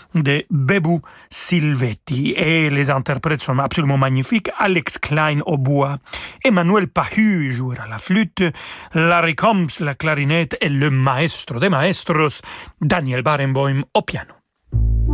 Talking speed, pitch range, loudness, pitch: 125 wpm, 135-170 Hz, -18 LUFS, 150 Hz